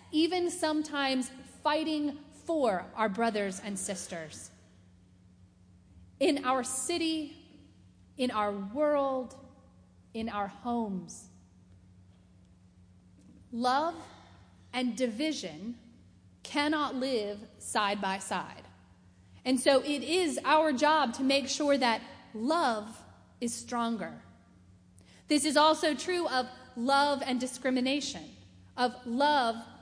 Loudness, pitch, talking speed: -30 LUFS, 235 Hz, 95 wpm